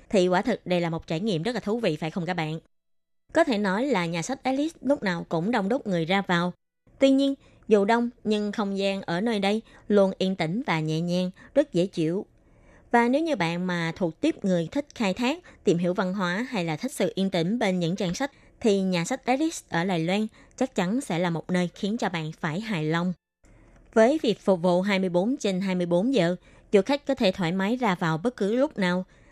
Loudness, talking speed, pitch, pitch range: -26 LUFS, 235 wpm, 195 Hz, 175-235 Hz